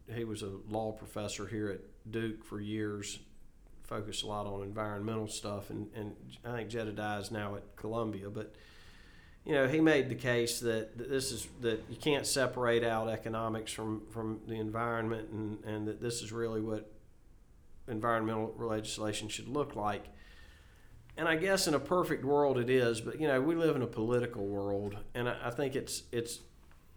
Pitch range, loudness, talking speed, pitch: 105-120 Hz, -35 LUFS, 180 wpm, 110 Hz